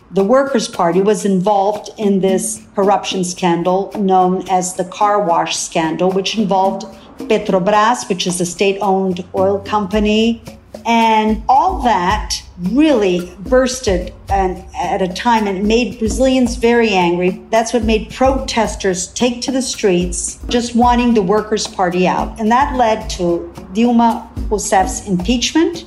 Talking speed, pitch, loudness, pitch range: 135 wpm, 205 Hz, -15 LUFS, 190-230 Hz